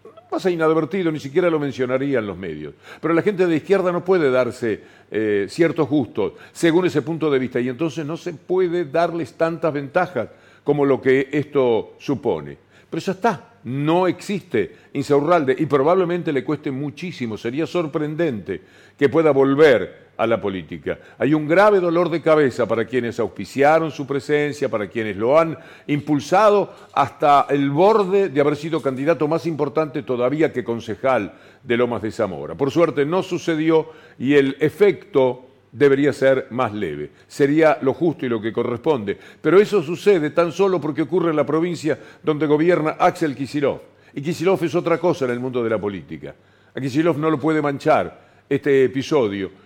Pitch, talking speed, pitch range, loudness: 150 Hz, 170 wpm, 130-170 Hz, -20 LUFS